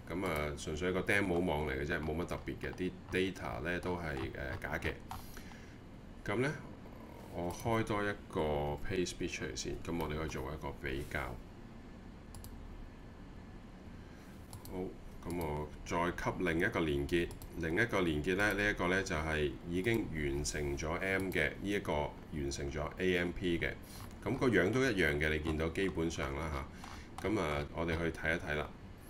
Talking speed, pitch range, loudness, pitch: 245 characters per minute, 75-95 Hz, -36 LUFS, 85 Hz